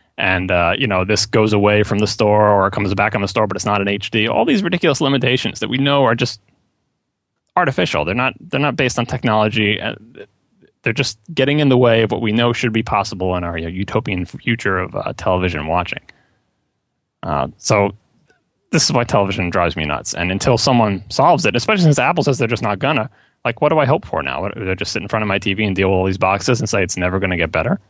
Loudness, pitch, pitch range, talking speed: -17 LUFS, 105 Hz, 95-125 Hz, 245 wpm